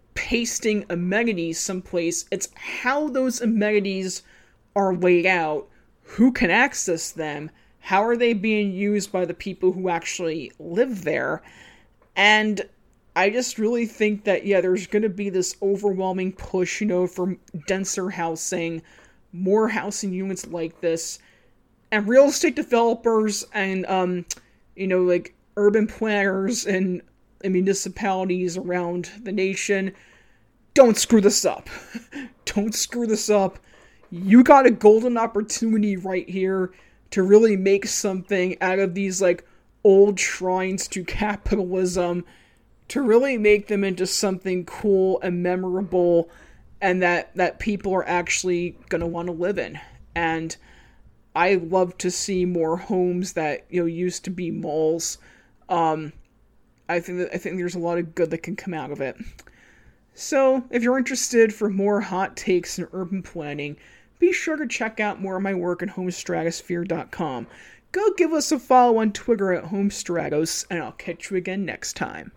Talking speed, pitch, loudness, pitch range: 150 wpm, 190 Hz, -22 LUFS, 180-215 Hz